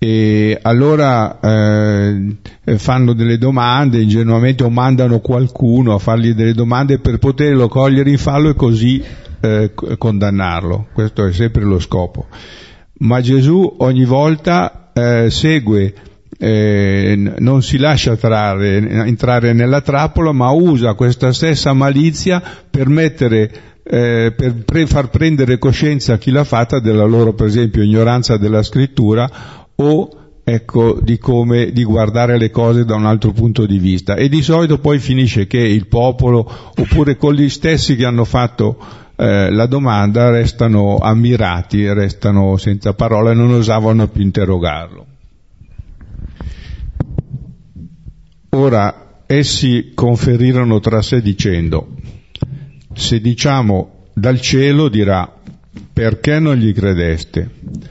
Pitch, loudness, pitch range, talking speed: 115 Hz, -13 LUFS, 105-130 Hz, 125 wpm